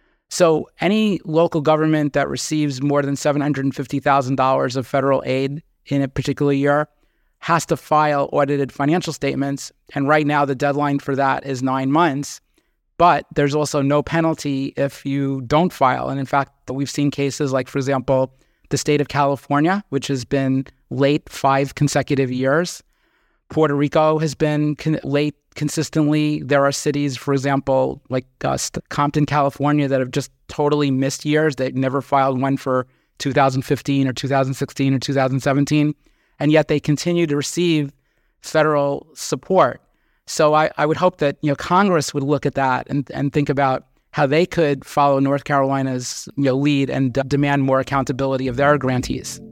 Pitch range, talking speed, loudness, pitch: 135-150 Hz, 165 wpm, -19 LUFS, 140 Hz